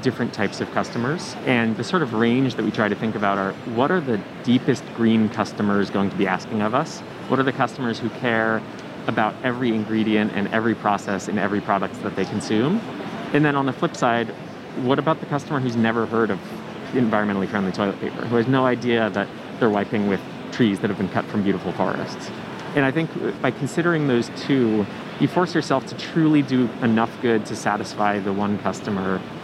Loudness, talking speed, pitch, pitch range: -22 LUFS, 205 wpm, 115 Hz, 105-130 Hz